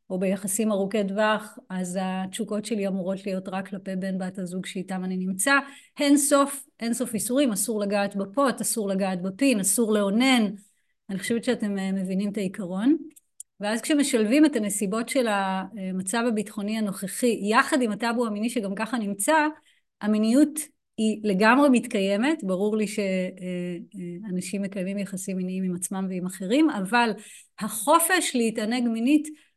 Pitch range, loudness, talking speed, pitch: 190-245 Hz, -25 LUFS, 140 wpm, 215 Hz